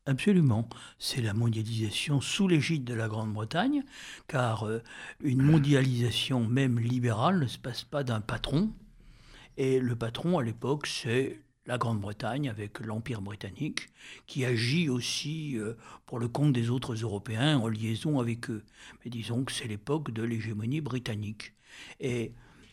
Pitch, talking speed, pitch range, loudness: 125 Hz, 140 wpm, 115-140 Hz, -30 LUFS